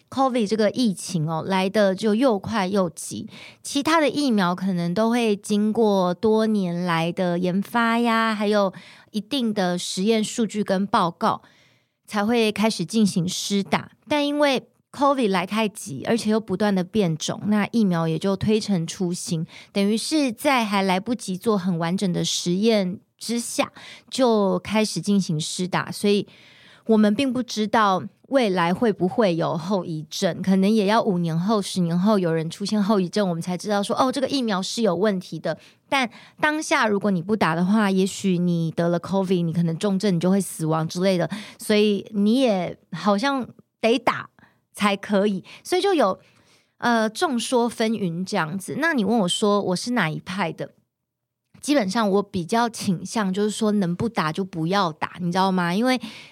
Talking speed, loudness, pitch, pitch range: 265 characters per minute, -22 LUFS, 205 Hz, 180-225 Hz